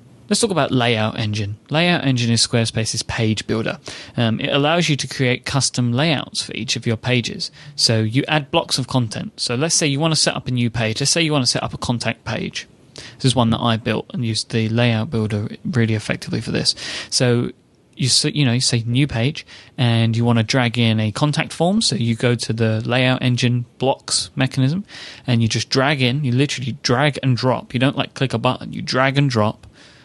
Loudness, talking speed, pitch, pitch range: -19 LUFS, 225 wpm, 125 Hz, 115-140 Hz